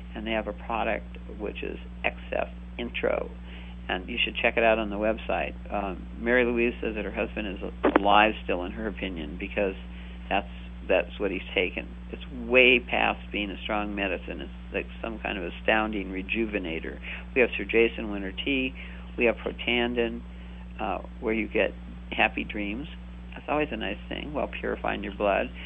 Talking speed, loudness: 180 wpm, -27 LUFS